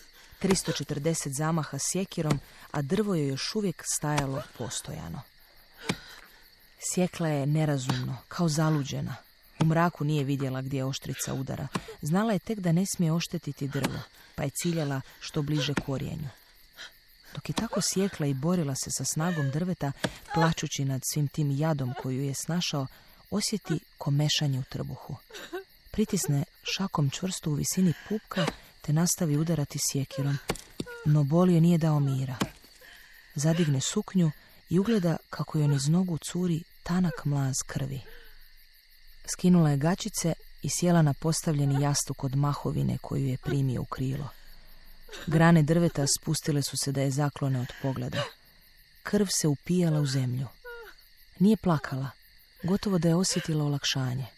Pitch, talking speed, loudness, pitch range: 155 Hz, 135 wpm, -28 LUFS, 140-175 Hz